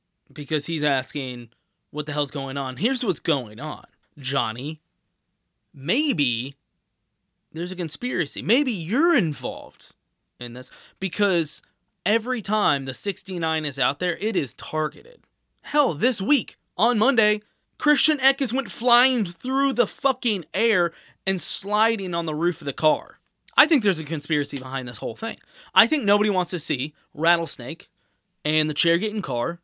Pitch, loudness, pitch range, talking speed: 175 Hz, -23 LUFS, 145-225 Hz, 150 wpm